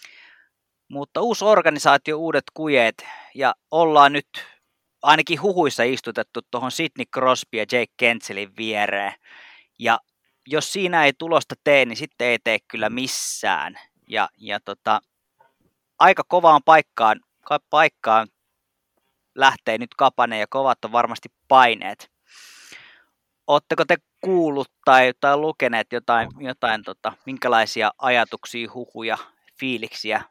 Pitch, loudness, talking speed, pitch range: 135 Hz, -20 LUFS, 115 wpm, 120-155 Hz